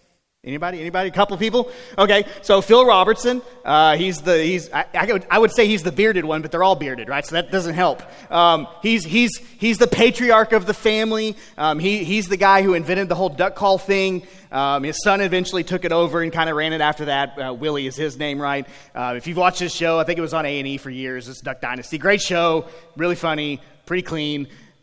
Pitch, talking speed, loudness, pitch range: 175 Hz, 225 wpm, -19 LUFS, 155-200 Hz